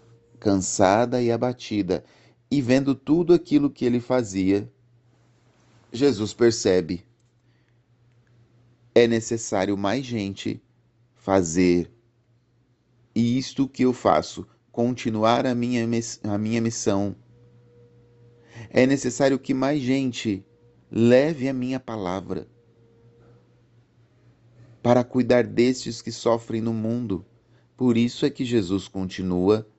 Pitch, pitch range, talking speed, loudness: 120 Hz, 115-125 Hz, 100 wpm, -23 LUFS